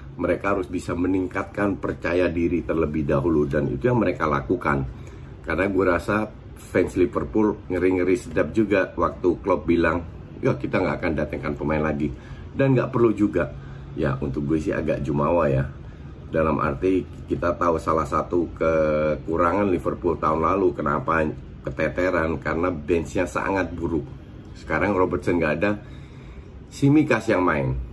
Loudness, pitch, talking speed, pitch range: -23 LUFS, 85 Hz, 140 wpm, 75-95 Hz